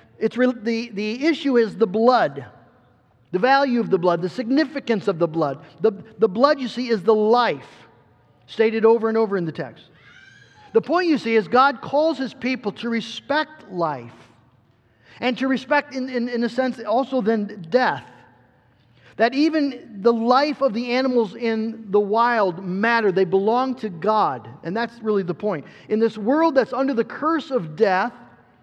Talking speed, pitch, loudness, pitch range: 180 wpm, 225 Hz, -21 LUFS, 175-250 Hz